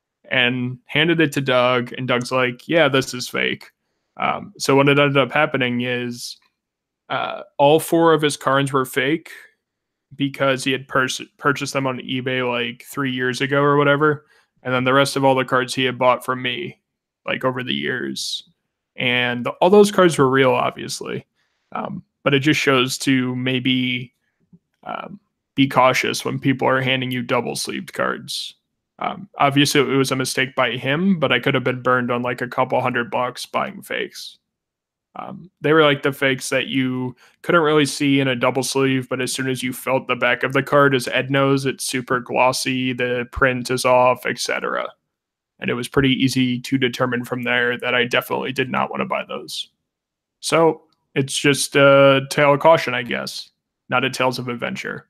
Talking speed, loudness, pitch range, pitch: 190 wpm, -19 LUFS, 125-140 Hz, 130 Hz